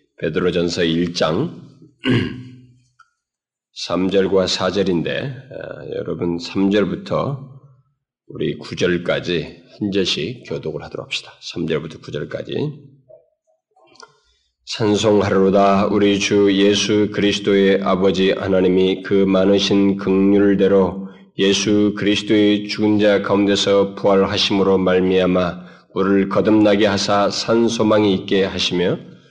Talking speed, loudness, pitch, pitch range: 230 characters per minute, -17 LUFS, 100 Hz, 95-105 Hz